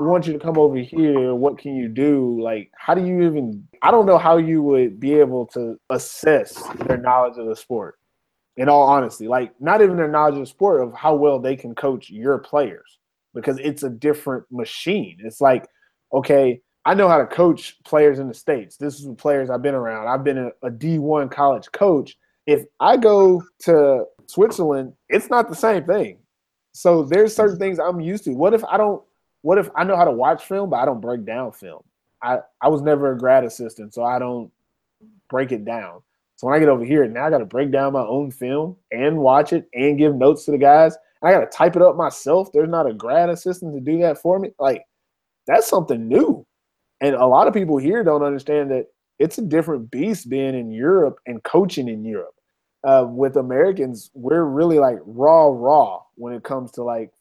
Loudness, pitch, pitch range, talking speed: -18 LUFS, 145 Hz, 130-170 Hz, 215 wpm